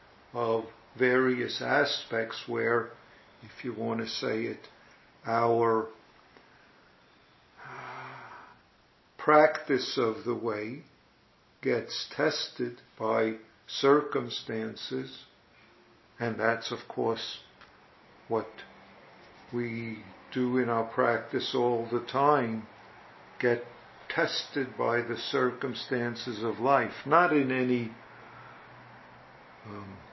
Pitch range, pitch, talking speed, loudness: 110-125 Hz, 115 Hz, 85 wpm, -29 LUFS